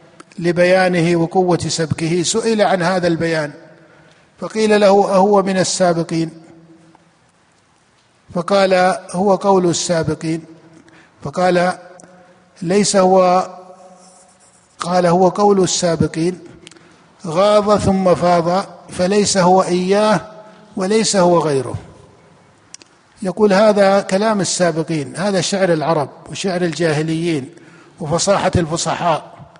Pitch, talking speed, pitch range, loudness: 180 Hz, 85 wpm, 165-190 Hz, -15 LUFS